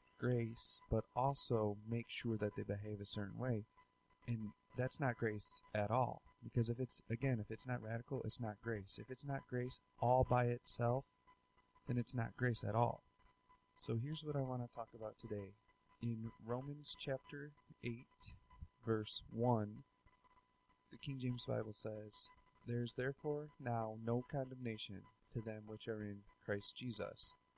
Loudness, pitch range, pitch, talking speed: -43 LUFS, 110-125 Hz, 115 Hz, 160 wpm